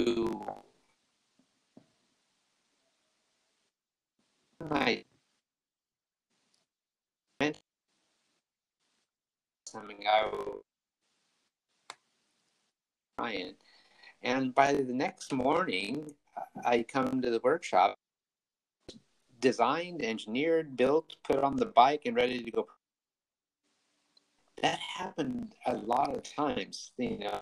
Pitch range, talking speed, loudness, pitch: 120-155 Hz, 65 wpm, -31 LUFS, 130 Hz